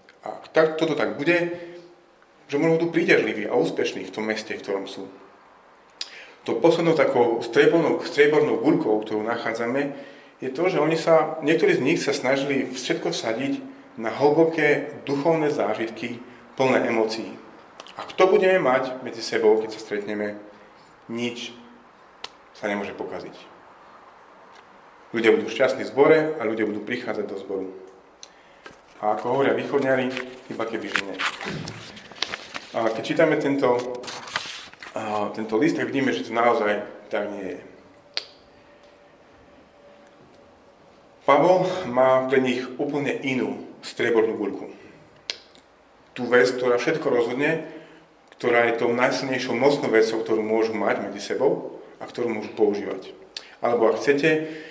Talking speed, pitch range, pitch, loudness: 130 wpm, 110-155 Hz, 130 Hz, -23 LUFS